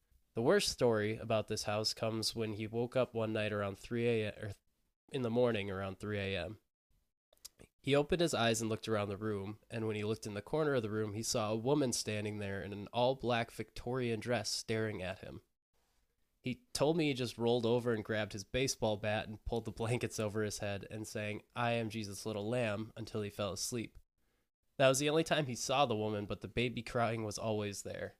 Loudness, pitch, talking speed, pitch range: -36 LUFS, 110 Hz, 215 wpm, 105-120 Hz